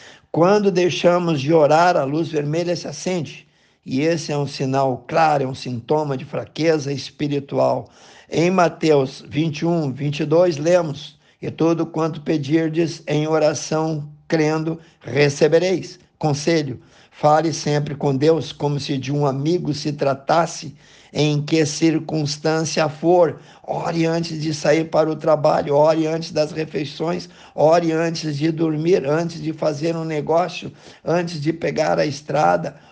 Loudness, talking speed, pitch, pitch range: -20 LUFS, 135 wpm, 155 Hz, 150-165 Hz